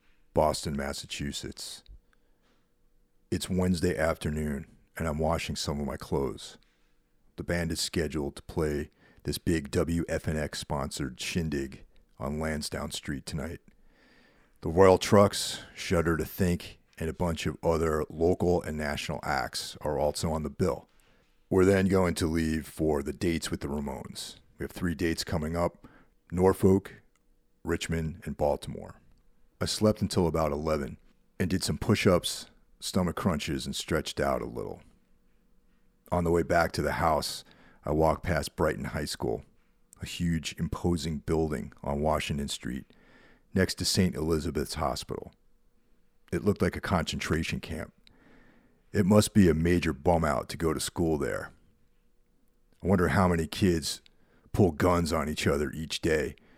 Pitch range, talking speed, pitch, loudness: 75-90 Hz, 150 wpm, 80 Hz, -29 LUFS